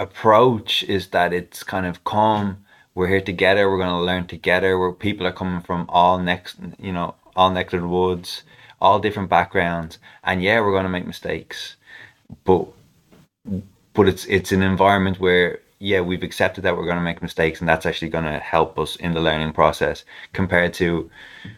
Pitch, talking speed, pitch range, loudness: 90 Hz, 185 wpm, 85-95 Hz, -20 LUFS